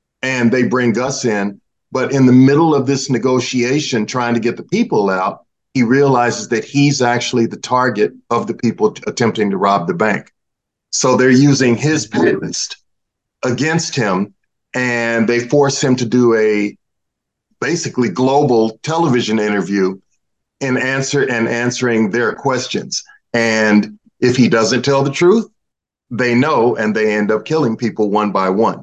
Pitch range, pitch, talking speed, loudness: 115-135 Hz, 125 Hz, 155 wpm, -15 LUFS